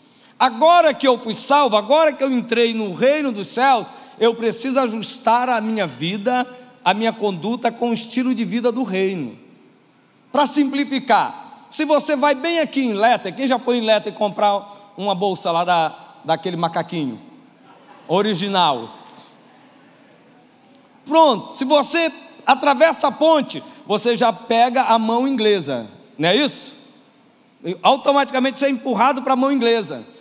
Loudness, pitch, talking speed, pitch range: -18 LUFS, 250 Hz, 150 wpm, 220-275 Hz